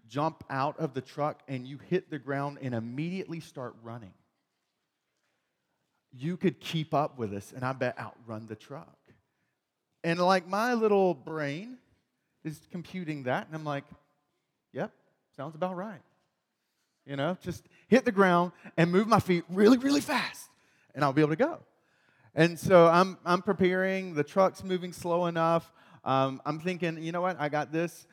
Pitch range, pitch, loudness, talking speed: 140-180 Hz, 160 Hz, -29 LUFS, 170 wpm